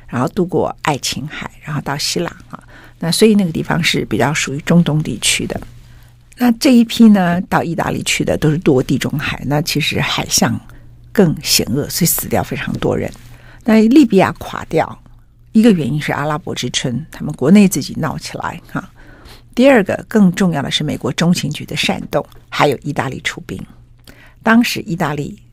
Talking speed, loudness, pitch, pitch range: 275 characters per minute, -15 LUFS, 150 Hz, 125-190 Hz